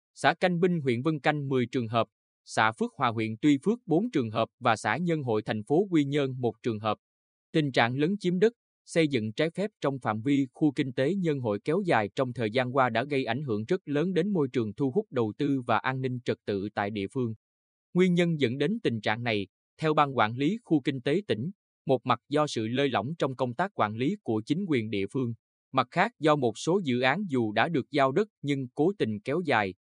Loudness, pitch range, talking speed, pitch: -28 LUFS, 115-155 Hz, 245 wpm, 130 Hz